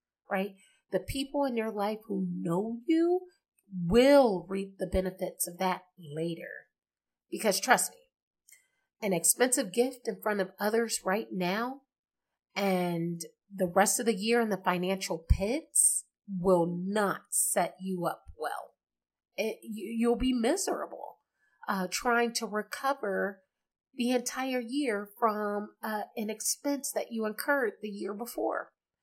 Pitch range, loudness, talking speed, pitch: 190-245 Hz, -30 LUFS, 135 wpm, 210 Hz